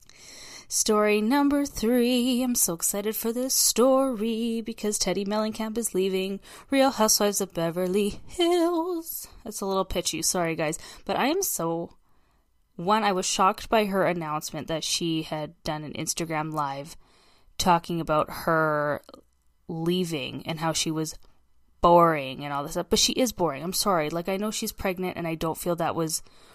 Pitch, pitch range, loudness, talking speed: 180 Hz, 160-220 Hz, -25 LUFS, 165 wpm